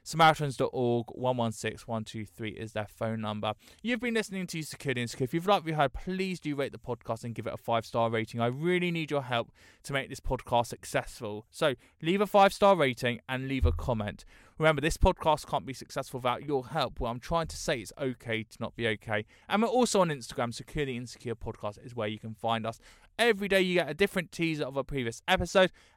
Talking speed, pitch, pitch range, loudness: 215 wpm, 130 Hz, 115-160 Hz, -30 LUFS